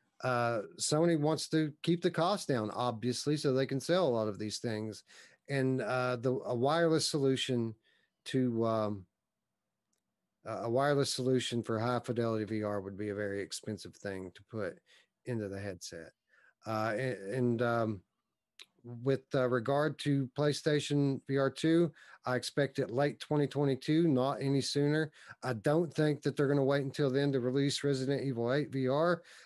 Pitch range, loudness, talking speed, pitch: 115-145 Hz, -33 LUFS, 160 wpm, 130 Hz